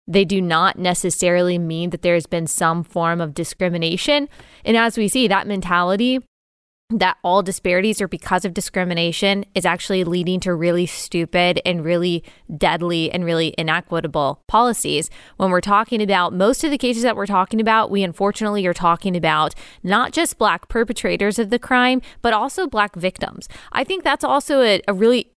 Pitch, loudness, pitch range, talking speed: 190 Hz, -19 LUFS, 175-220 Hz, 175 wpm